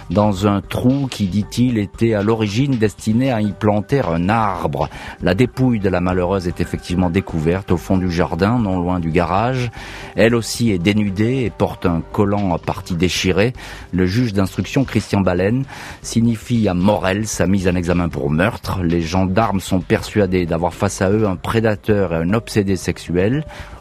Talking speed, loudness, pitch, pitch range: 175 wpm, -18 LUFS, 100 Hz, 90-115 Hz